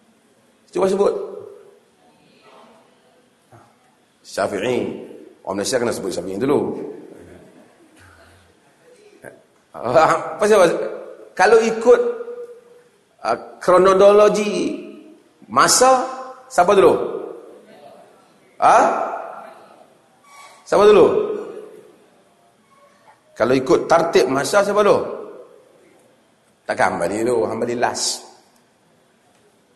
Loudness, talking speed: -17 LUFS, 70 wpm